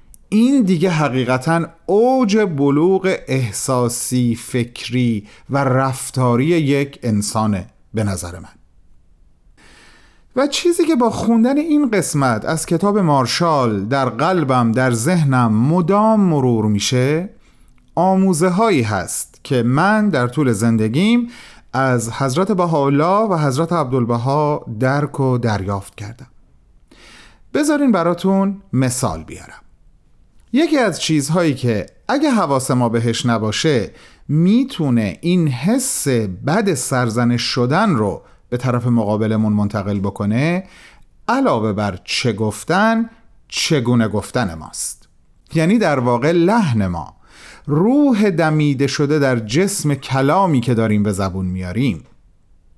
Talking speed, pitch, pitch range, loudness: 110 wpm, 135 Hz, 115-180 Hz, -17 LUFS